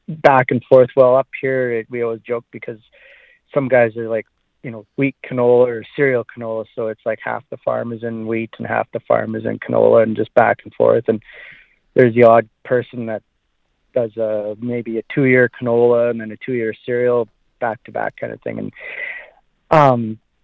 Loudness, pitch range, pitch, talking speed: -17 LUFS, 115-130 Hz, 120 Hz, 205 wpm